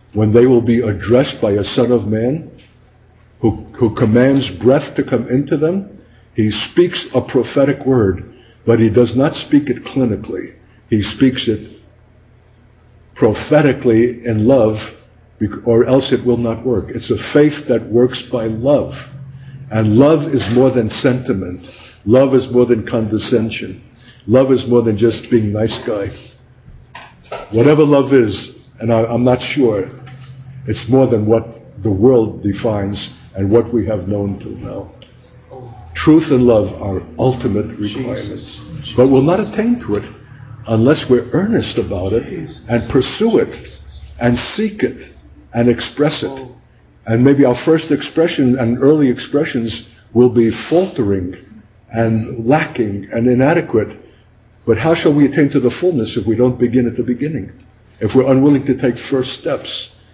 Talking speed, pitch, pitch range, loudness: 155 wpm, 120 Hz, 110-130 Hz, -15 LUFS